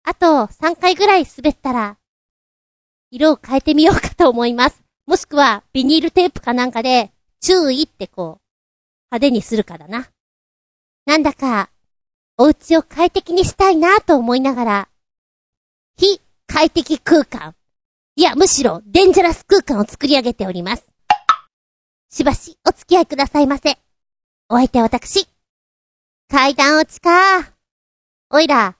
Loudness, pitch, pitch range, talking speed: -15 LUFS, 290 Hz, 245-345 Hz, 270 characters per minute